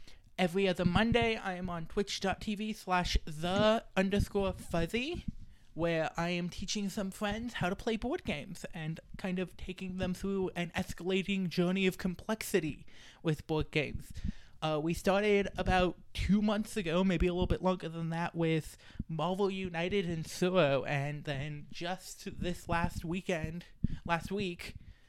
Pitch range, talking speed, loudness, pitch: 165-195 Hz, 150 wpm, -34 LUFS, 180 Hz